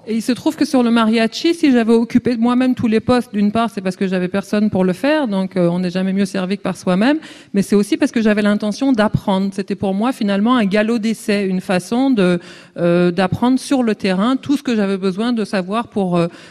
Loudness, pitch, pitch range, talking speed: -17 LUFS, 210 Hz, 195-245 Hz, 240 wpm